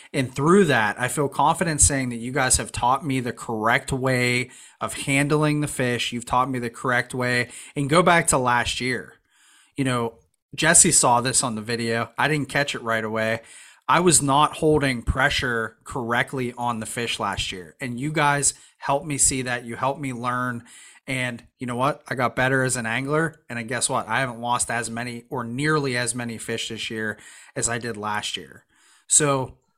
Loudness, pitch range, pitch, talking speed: -22 LUFS, 120-140 Hz, 125 Hz, 200 wpm